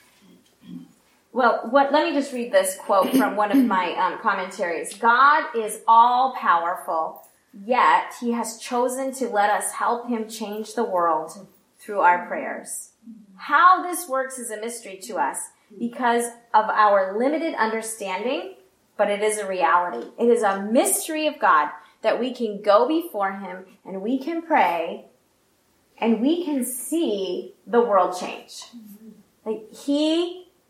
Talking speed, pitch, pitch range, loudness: 145 wpm, 235 Hz, 205-280 Hz, -22 LUFS